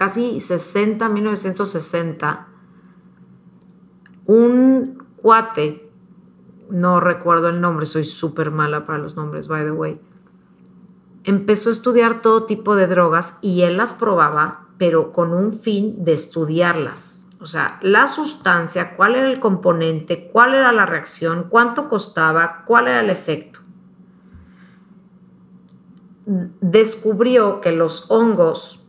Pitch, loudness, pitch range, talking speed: 185 Hz, -17 LUFS, 170-215 Hz, 120 wpm